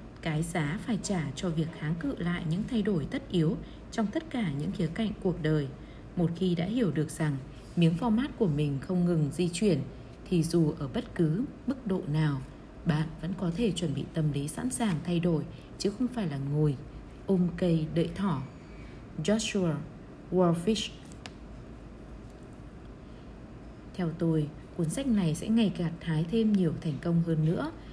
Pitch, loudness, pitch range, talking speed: 170 Hz, -30 LUFS, 155-195 Hz, 175 wpm